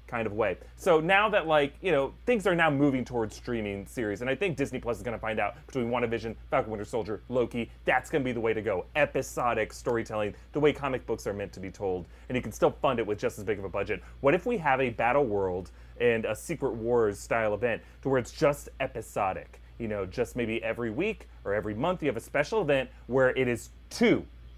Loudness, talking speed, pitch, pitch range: -29 LUFS, 245 wpm, 120 Hz, 110-145 Hz